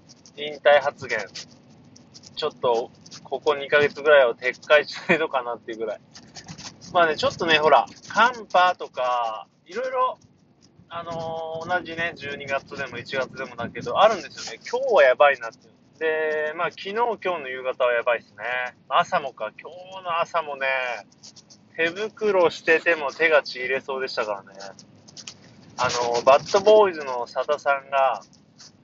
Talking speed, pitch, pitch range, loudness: 295 characters per minute, 150 Hz, 130-175 Hz, -22 LUFS